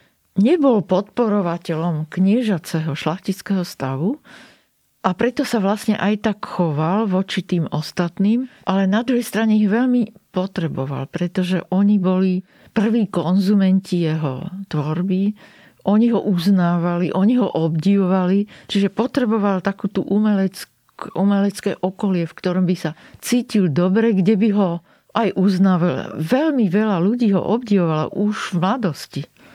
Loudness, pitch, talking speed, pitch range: -19 LUFS, 195 Hz, 120 wpm, 175-215 Hz